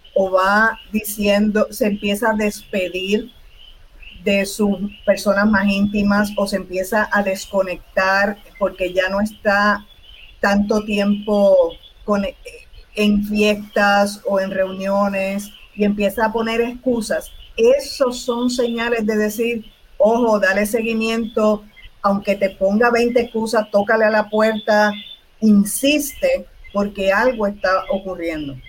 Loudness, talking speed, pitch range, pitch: -18 LUFS, 115 wpm, 200-225 Hz, 210 Hz